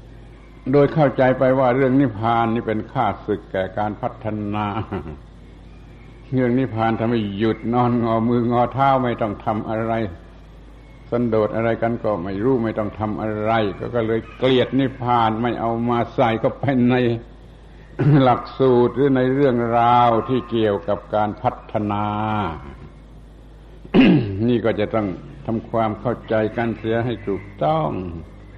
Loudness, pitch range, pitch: -20 LUFS, 105-125 Hz, 115 Hz